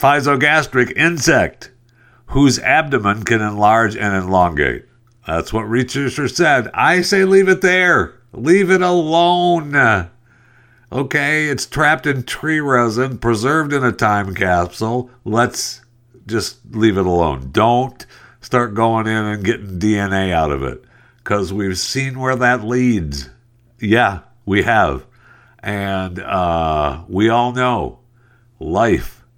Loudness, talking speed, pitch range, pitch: -16 LUFS, 125 wpm, 105-135 Hz, 120 Hz